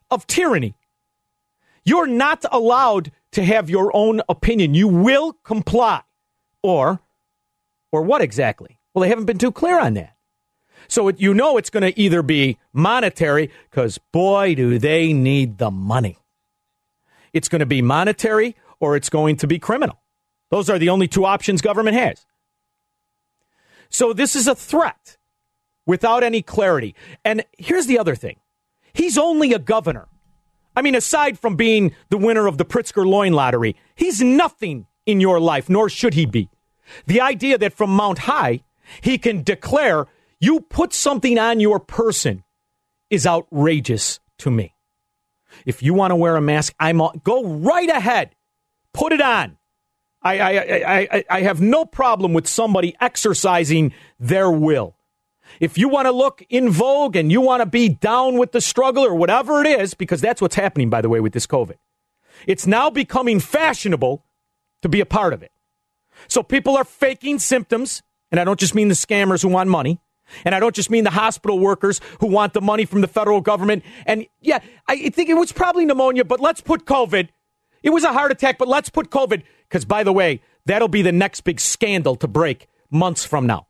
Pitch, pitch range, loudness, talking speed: 195 Hz, 150-245 Hz, -18 LUFS, 180 wpm